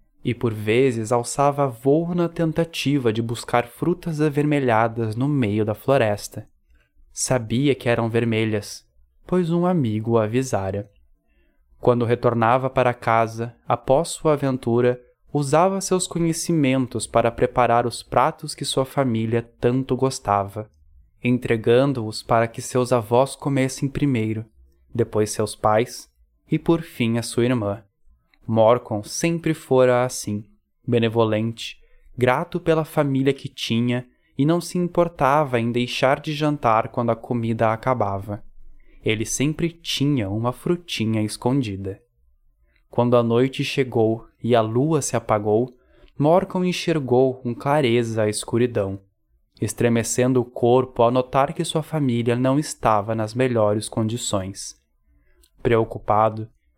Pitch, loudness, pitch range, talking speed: 120 Hz, -21 LUFS, 110-140 Hz, 125 wpm